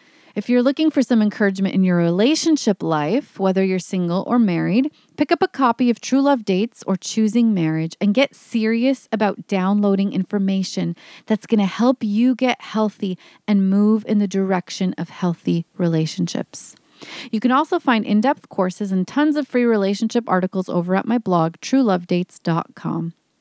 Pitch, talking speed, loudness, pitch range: 210 Hz, 165 wpm, -19 LUFS, 185-245 Hz